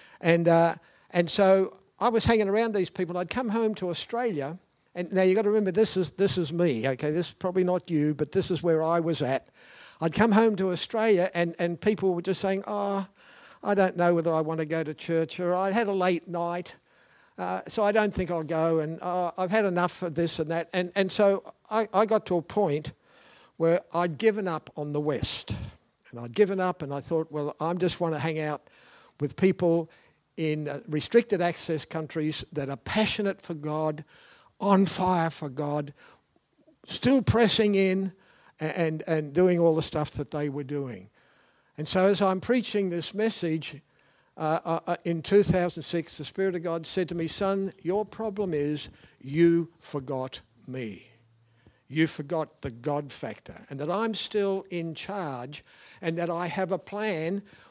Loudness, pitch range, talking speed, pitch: -27 LUFS, 155-195 Hz, 195 wpm, 175 Hz